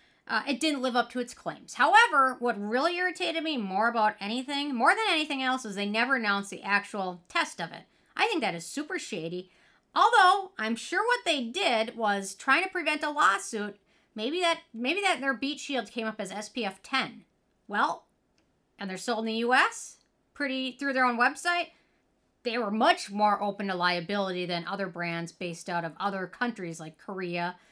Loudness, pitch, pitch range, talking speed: -28 LUFS, 235 Hz, 200-280 Hz, 195 wpm